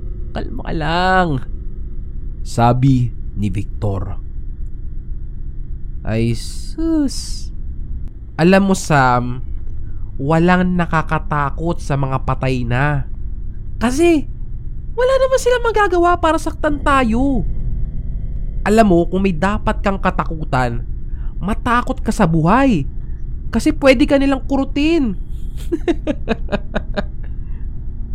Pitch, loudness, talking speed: 160 Hz, -17 LUFS, 85 wpm